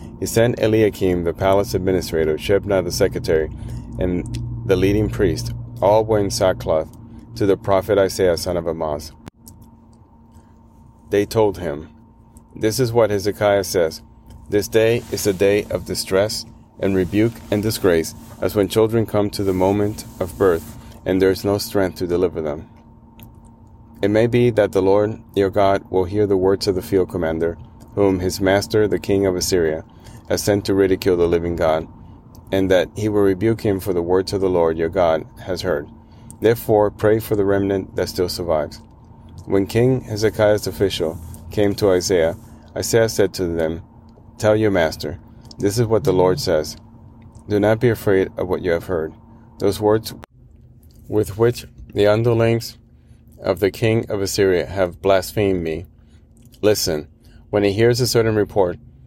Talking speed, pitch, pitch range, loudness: 165 wpm, 100 Hz, 95-115 Hz, -19 LUFS